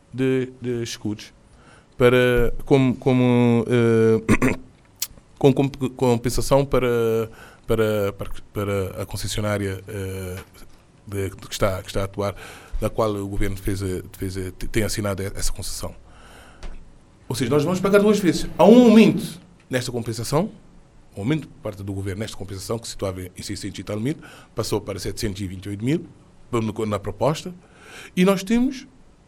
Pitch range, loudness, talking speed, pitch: 100-135 Hz, -22 LUFS, 145 wpm, 115 Hz